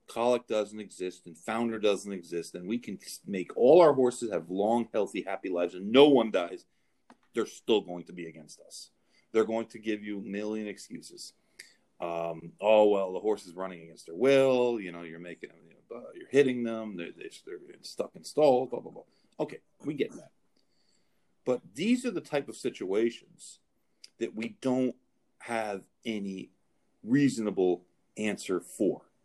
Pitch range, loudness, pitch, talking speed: 90-120 Hz, -29 LUFS, 110 Hz, 170 wpm